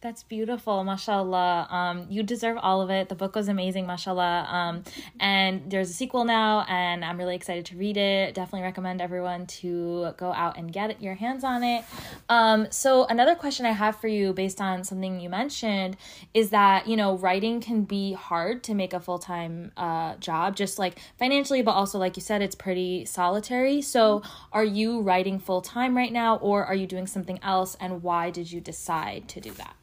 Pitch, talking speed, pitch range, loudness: 195 Hz, 195 wpm, 180-220 Hz, -26 LUFS